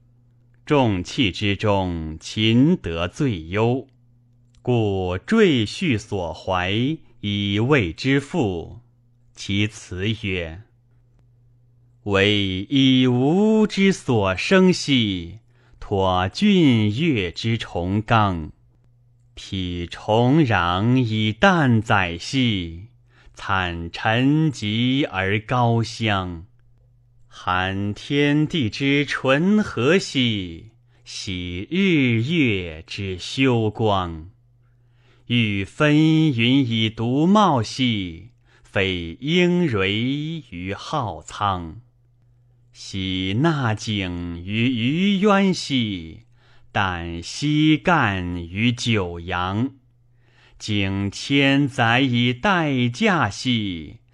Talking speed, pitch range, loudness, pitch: 100 characters per minute, 100-130 Hz, -21 LUFS, 120 Hz